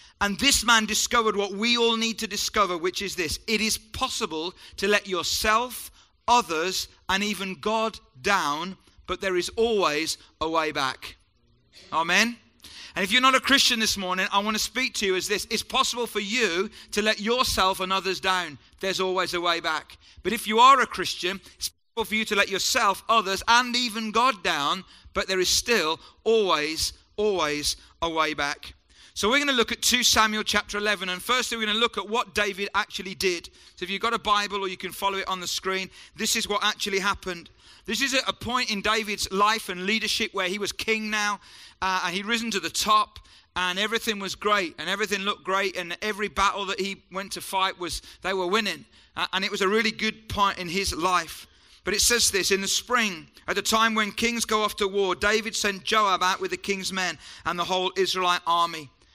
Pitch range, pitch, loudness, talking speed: 185-220 Hz, 200 Hz, -24 LUFS, 215 wpm